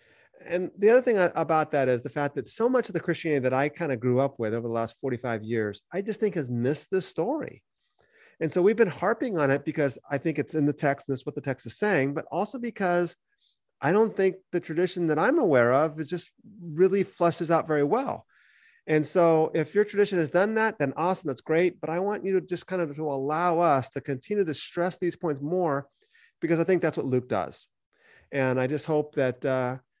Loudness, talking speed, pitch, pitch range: -26 LUFS, 235 wpm, 160 Hz, 140-185 Hz